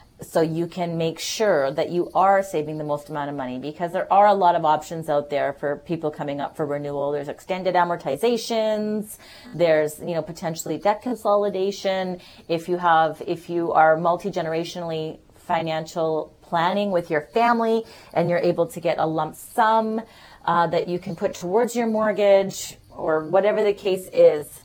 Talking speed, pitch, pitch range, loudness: 175 wpm, 170 Hz, 155-195 Hz, -23 LUFS